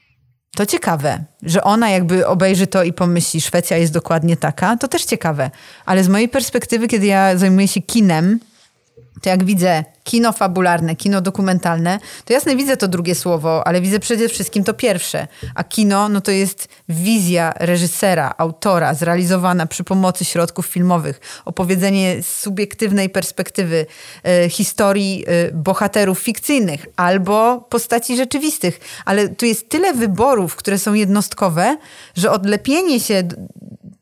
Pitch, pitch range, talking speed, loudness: 190 Hz, 175-210 Hz, 140 wpm, -16 LUFS